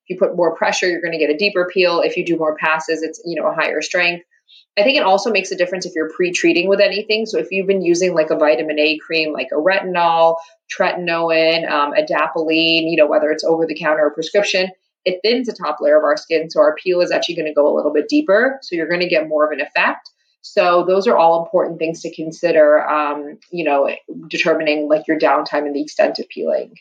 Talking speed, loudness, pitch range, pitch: 240 wpm, -16 LUFS, 155-185 Hz, 165 Hz